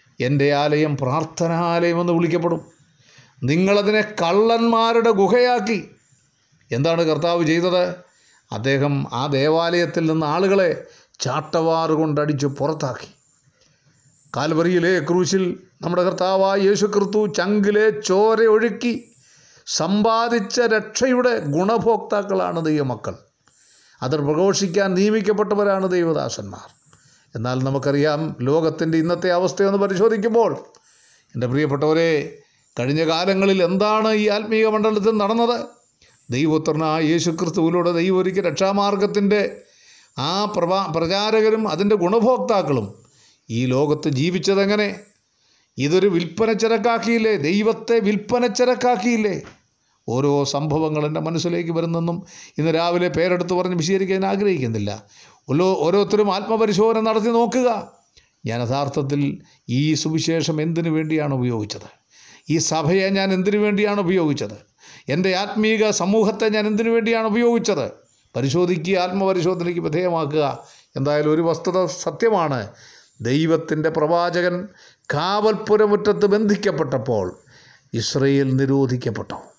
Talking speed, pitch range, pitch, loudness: 90 wpm, 150-210 Hz, 175 Hz, -19 LUFS